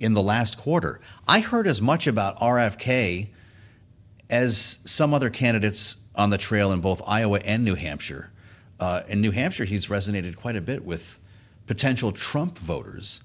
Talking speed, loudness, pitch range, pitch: 165 wpm, -23 LUFS, 100-120 Hz, 105 Hz